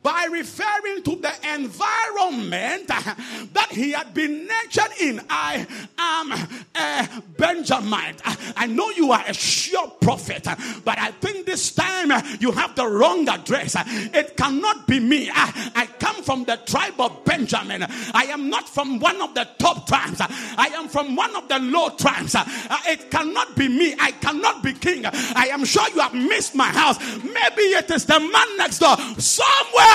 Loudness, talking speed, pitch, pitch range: -20 LUFS, 170 wpm, 300 Hz, 255-345 Hz